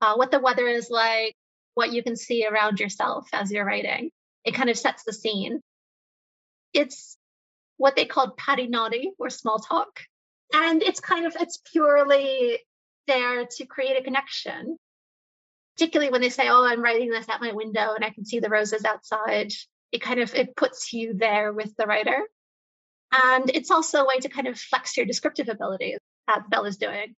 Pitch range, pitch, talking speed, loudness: 220-275 Hz, 245 Hz, 185 wpm, -24 LUFS